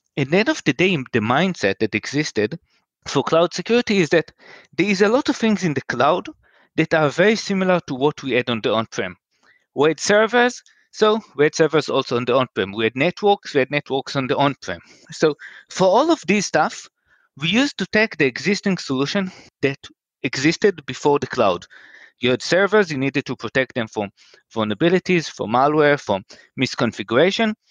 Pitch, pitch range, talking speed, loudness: 155 Hz, 135-190 Hz, 195 wpm, -19 LUFS